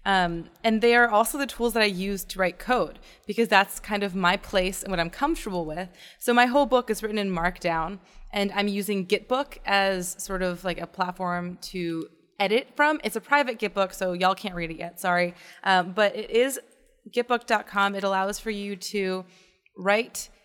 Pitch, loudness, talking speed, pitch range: 200 Hz, -25 LUFS, 195 wpm, 185-220 Hz